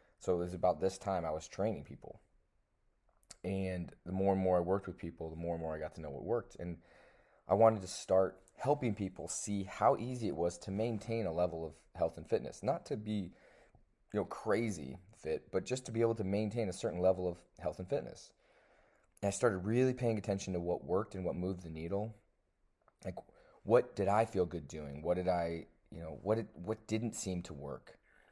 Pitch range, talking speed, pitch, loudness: 85-105 Hz, 220 wpm, 95 Hz, -37 LUFS